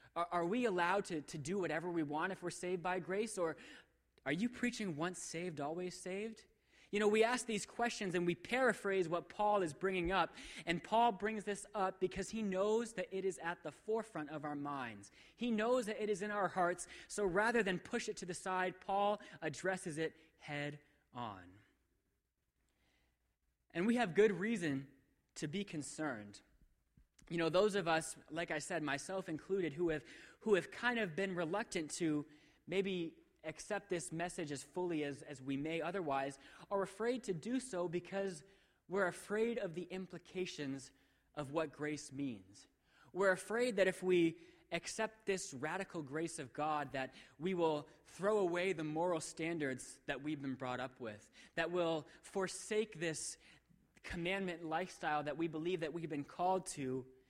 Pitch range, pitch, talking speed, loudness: 150-195 Hz, 175 Hz, 175 wpm, -40 LUFS